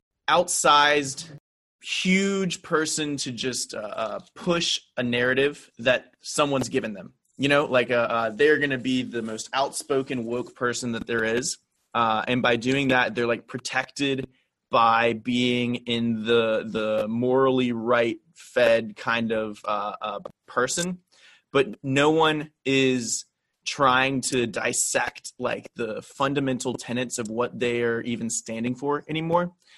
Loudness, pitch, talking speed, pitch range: -24 LUFS, 125 Hz, 145 wpm, 120-145 Hz